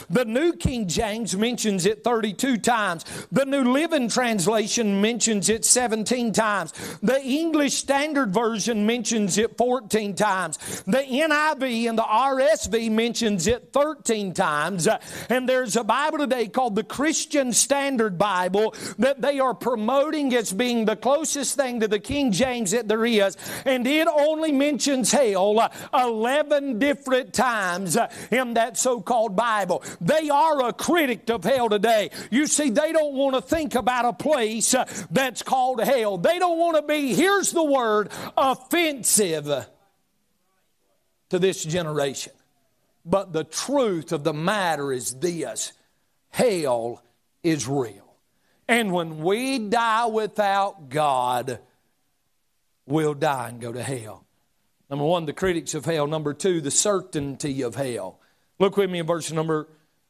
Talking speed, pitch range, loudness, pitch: 145 wpm, 185-265 Hz, -23 LUFS, 225 Hz